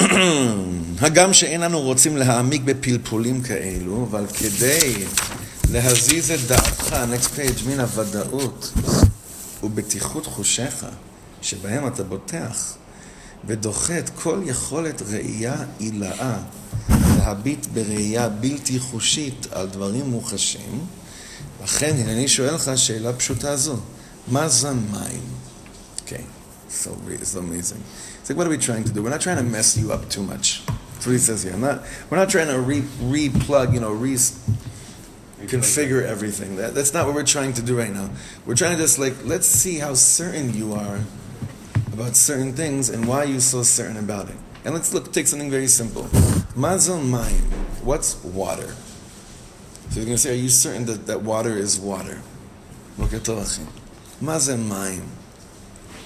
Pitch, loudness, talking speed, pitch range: 120 Hz, -20 LUFS, 150 wpm, 105-135 Hz